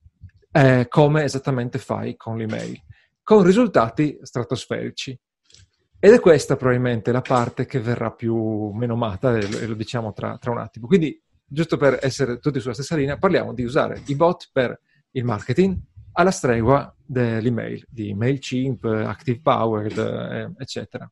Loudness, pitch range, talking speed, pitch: -21 LUFS, 115-140 Hz, 140 wpm, 125 Hz